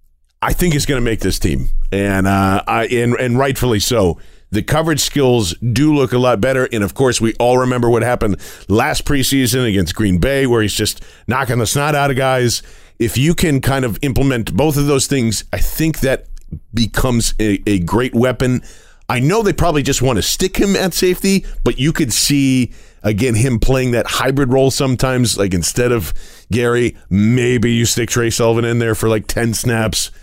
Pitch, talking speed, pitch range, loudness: 120 Hz, 200 wpm, 110-135 Hz, -15 LUFS